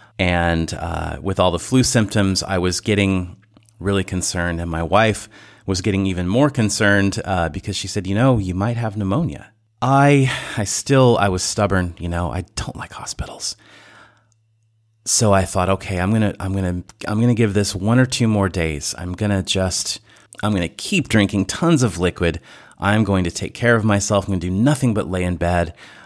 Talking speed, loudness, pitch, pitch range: 195 wpm, -19 LUFS, 100 Hz, 90-110 Hz